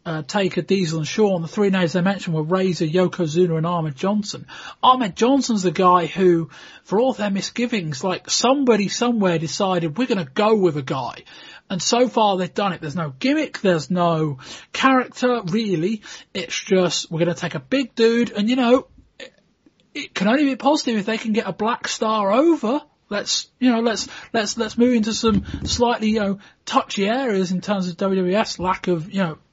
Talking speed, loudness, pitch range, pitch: 200 wpm, -20 LUFS, 180-235 Hz, 200 Hz